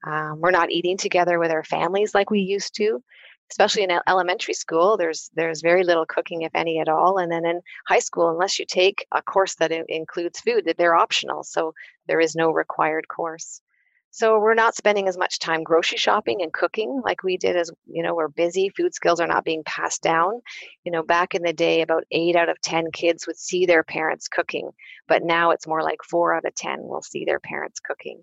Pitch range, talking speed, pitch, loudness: 165-195 Hz, 220 wpm, 170 Hz, -22 LUFS